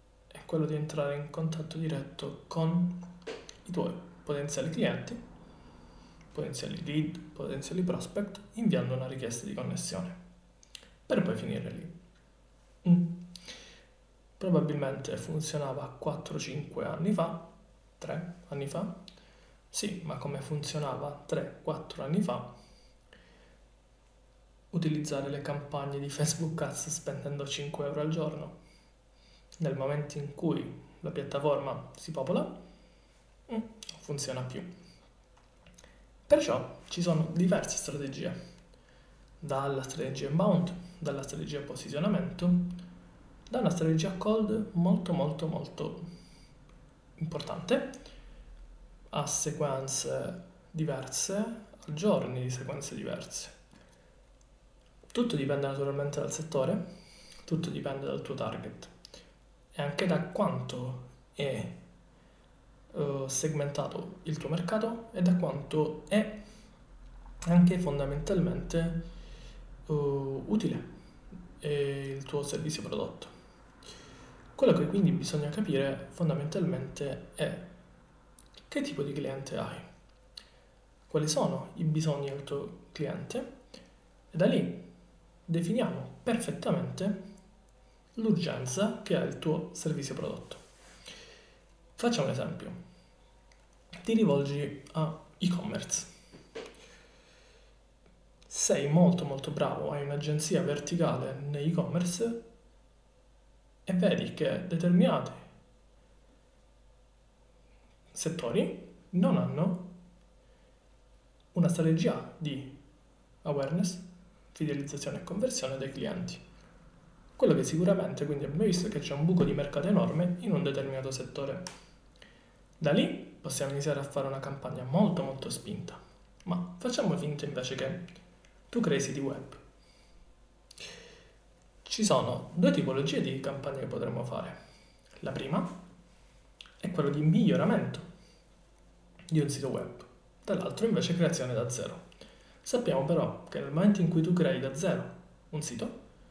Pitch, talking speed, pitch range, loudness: 160 Hz, 105 wpm, 145-180 Hz, -32 LUFS